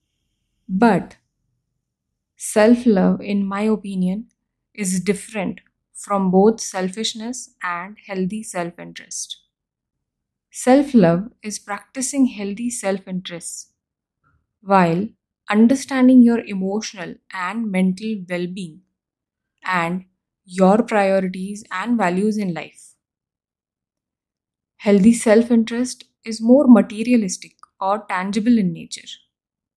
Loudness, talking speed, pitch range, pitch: -19 LUFS, 95 wpm, 185-225 Hz, 205 Hz